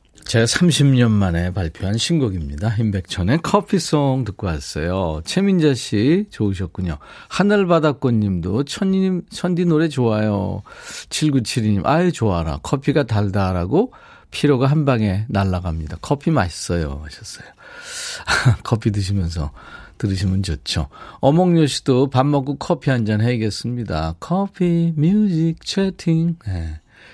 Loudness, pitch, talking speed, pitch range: -19 LUFS, 120 Hz, 270 characters per minute, 95-160 Hz